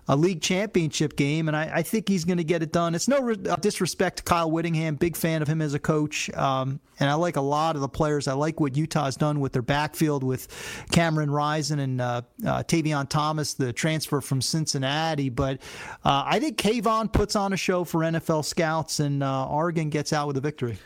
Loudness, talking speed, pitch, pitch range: -25 LUFS, 220 wpm, 155 Hz, 140-170 Hz